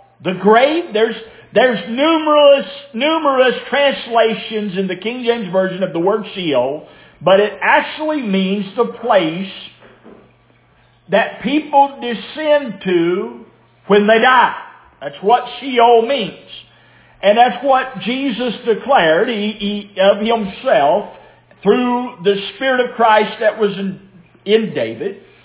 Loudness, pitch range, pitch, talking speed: -15 LUFS, 200-260 Hz, 225 Hz, 125 wpm